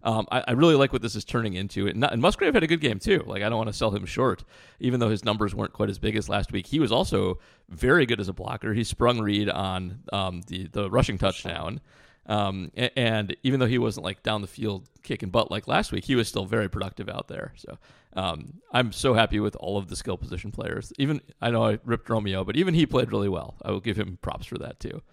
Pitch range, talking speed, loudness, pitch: 100-120 Hz, 260 wpm, -26 LUFS, 110 Hz